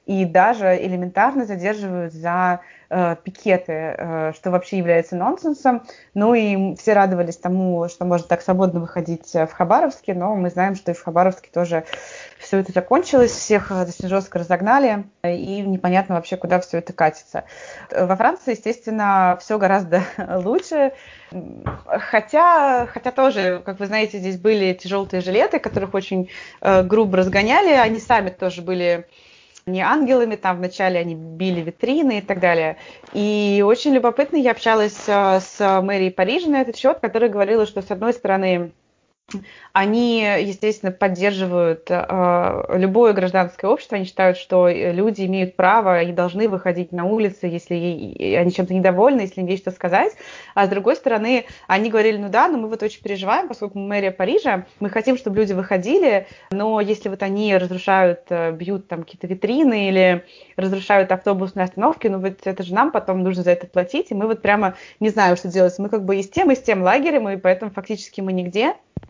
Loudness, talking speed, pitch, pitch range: -19 LUFS, 170 wpm, 195 Hz, 180-215 Hz